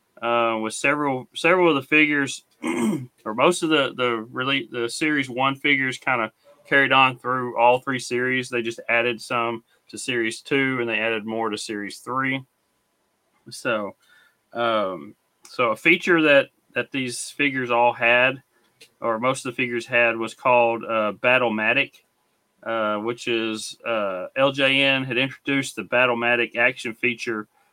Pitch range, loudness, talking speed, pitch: 115-135 Hz, -22 LUFS, 150 wpm, 125 Hz